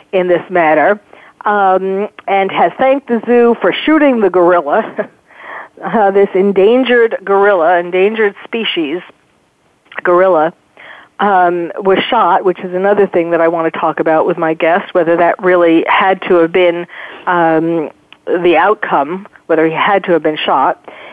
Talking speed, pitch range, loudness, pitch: 150 wpm, 170-200 Hz, -12 LUFS, 185 Hz